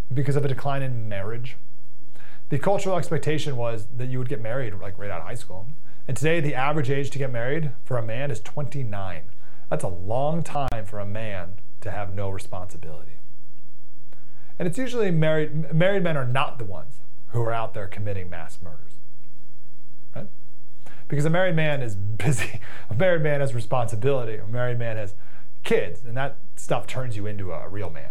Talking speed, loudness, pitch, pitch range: 190 wpm, -27 LUFS, 125 Hz, 105-145 Hz